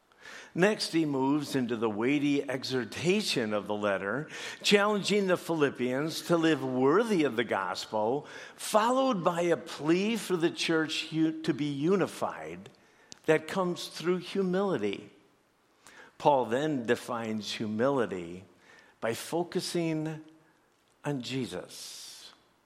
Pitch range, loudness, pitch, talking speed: 130-180 Hz, -30 LUFS, 160 Hz, 110 wpm